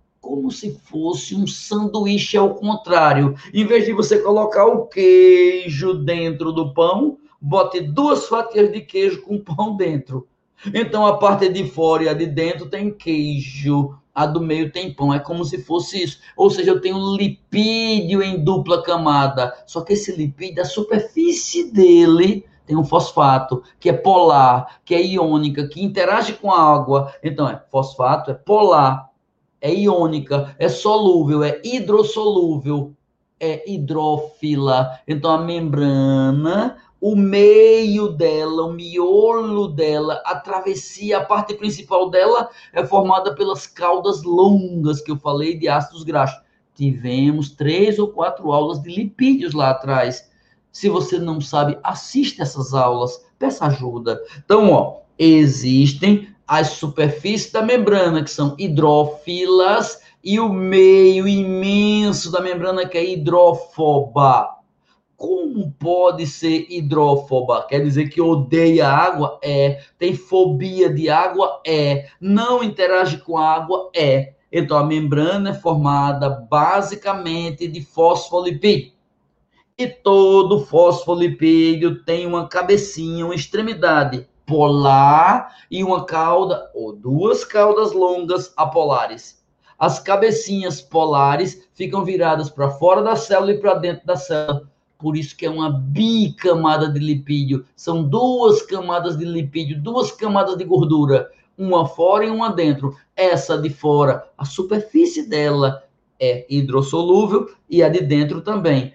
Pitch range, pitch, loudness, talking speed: 150-200 Hz, 170 Hz, -17 LUFS, 135 wpm